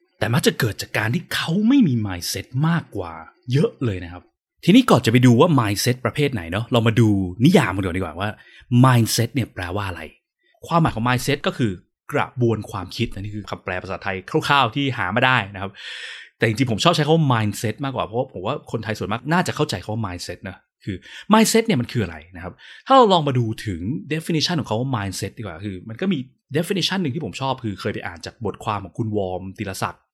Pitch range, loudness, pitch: 100-140 Hz, -21 LUFS, 115 Hz